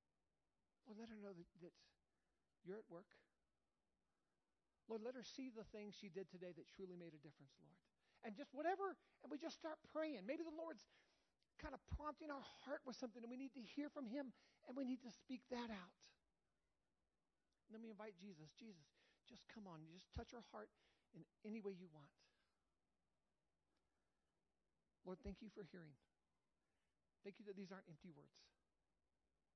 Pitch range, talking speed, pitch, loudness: 175-260 Hz, 175 wpm, 215 Hz, -55 LUFS